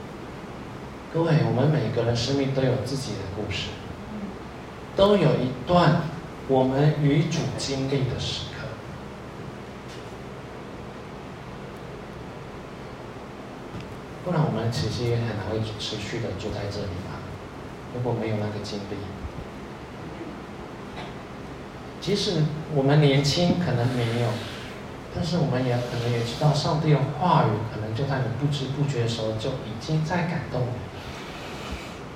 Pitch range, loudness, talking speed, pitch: 110-145 Hz, -26 LUFS, 185 characters per minute, 125 Hz